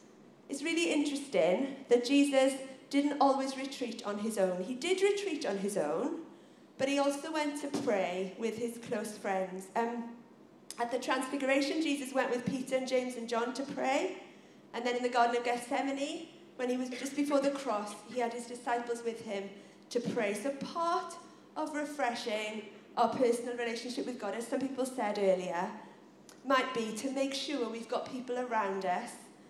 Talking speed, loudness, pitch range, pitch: 175 wpm, -34 LUFS, 230-275 Hz, 250 Hz